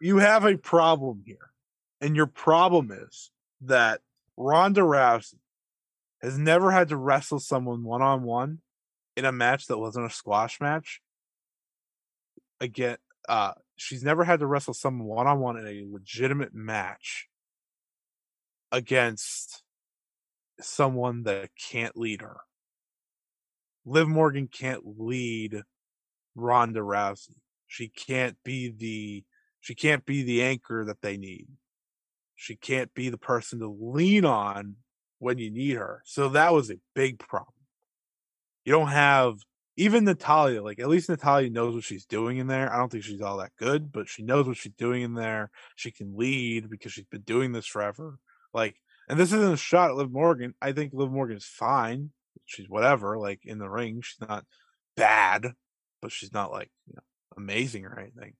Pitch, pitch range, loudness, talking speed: 125 Hz, 110-140 Hz, -26 LUFS, 160 wpm